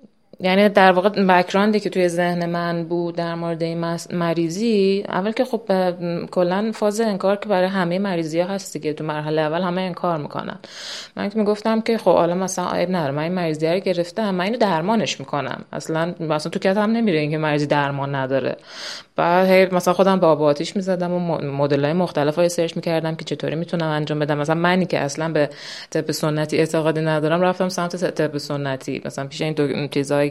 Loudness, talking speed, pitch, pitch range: -20 LUFS, 195 wpm, 170 Hz, 155-185 Hz